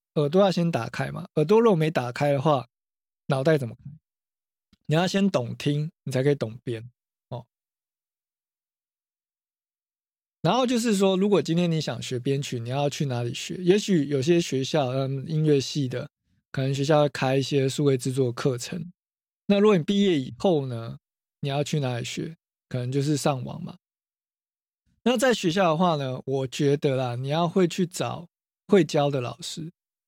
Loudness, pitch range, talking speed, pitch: -25 LUFS, 135-175 Hz, 240 characters per minute, 150 Hz